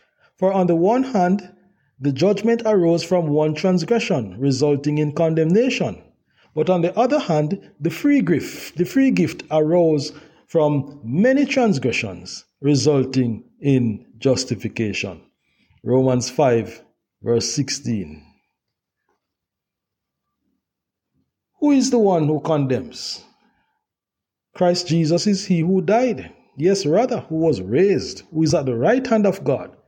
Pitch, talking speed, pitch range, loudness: 160 Hz, 125 wpm, 135-195 Hz, -19 LUFS